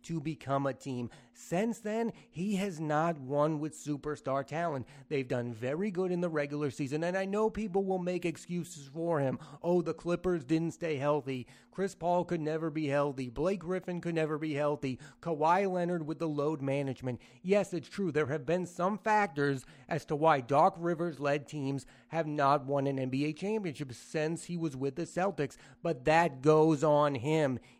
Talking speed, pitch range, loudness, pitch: 185 wpm, 140-175 Hz, -33 LUFS, 155 Hz